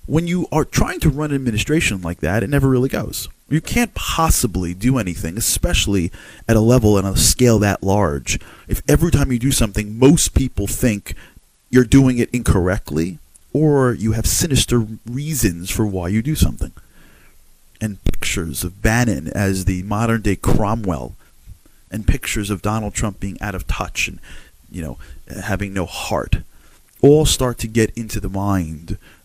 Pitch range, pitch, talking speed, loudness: 90-120 Hz, 105 Hz, 170 wpm, -18 LUFS